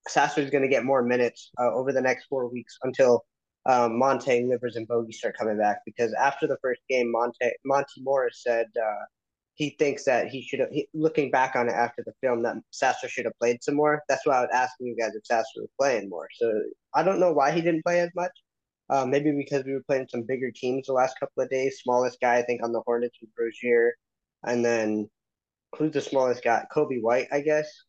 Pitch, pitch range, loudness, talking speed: 130 Hz, 120-140 Hz, -26 LUFS, 230 wpm